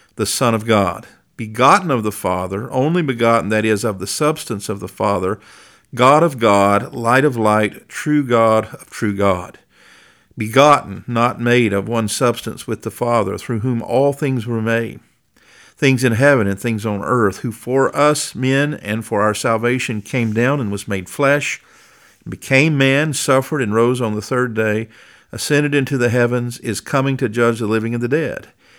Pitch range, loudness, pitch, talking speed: 110-135 Hz, -17 LUFS, 120 Hz, 180 wpm